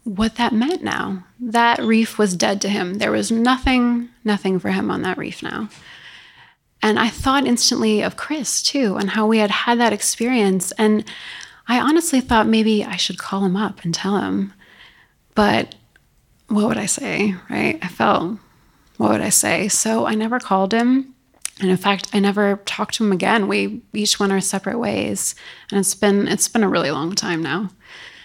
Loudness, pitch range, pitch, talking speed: -19 LUFS, 195-235 Hz, 210 Hz, 190 wpm